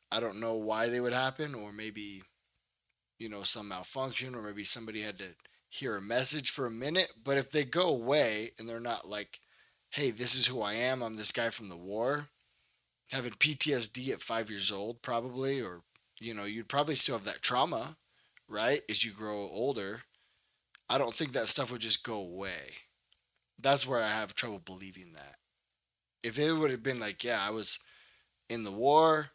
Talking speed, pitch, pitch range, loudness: 190 wpm, 115 Hz, 105-135 Hz, -25 LUFS